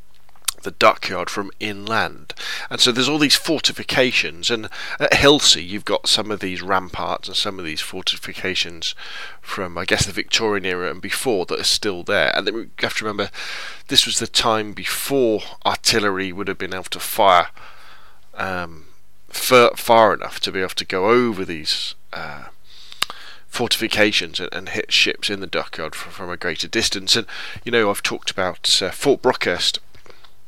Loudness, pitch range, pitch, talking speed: -19 LUFS, 90-115 Hz, 100 Hz, 175 wpm